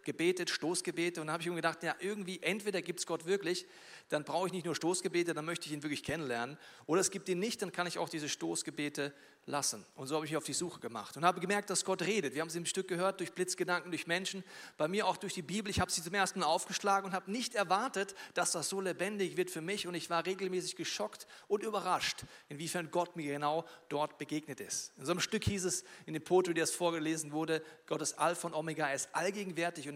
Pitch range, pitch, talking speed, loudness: 155-190 Hz, 175 Hz, 245 wpm, -36 LUFS